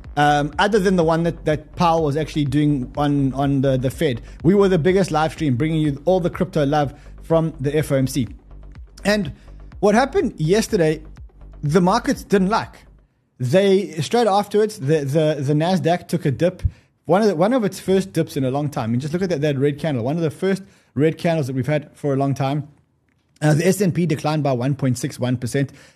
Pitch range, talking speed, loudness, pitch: 140-180 Hz, 205 wpm, -20 LUFS, 155 Hz